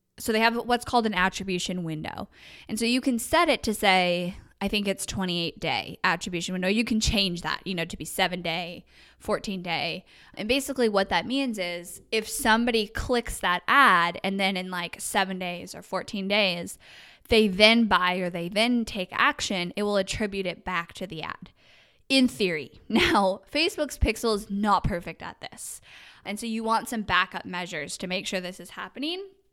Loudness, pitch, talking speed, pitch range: -25 LUFS, 195 Hz, 185 wpm, 180-230 Hz